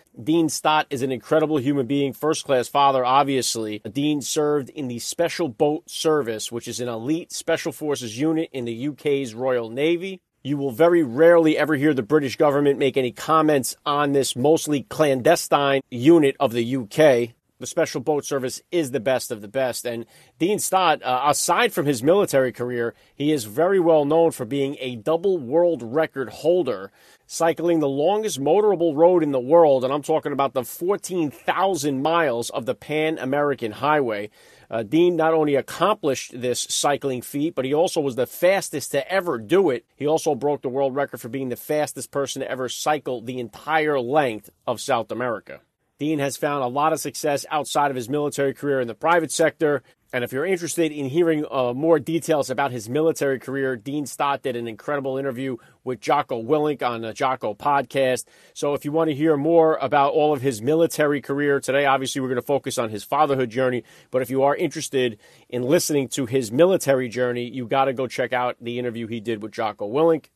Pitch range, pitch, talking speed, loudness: 130-155 Hz, 145 Hz, 195 wpm, -22 LUFS